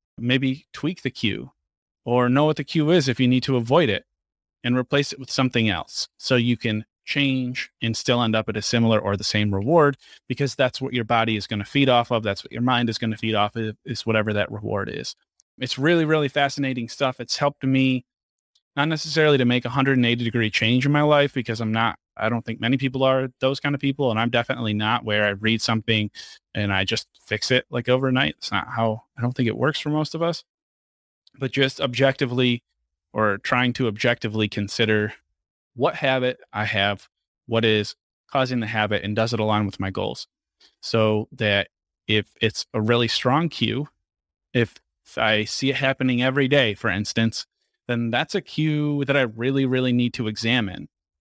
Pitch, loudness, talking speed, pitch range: 120 Hz, -22 LUFS, 205 wpm, 110-135 Hz